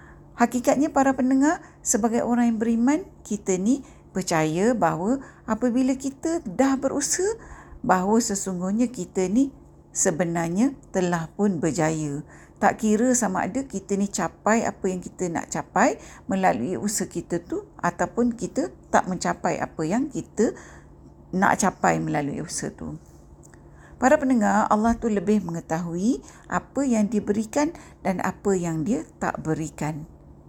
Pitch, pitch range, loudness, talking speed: 205 Hz, 170-250 Hz, -24 LUFS, 130 wpm